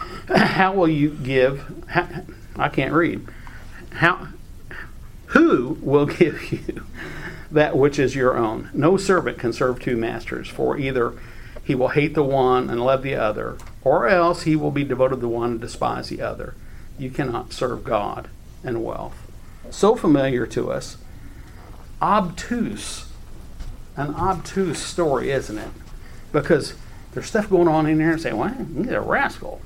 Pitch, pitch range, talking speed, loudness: 145 Hz, 125-170 Hz, 155 wpm, -21 LUFS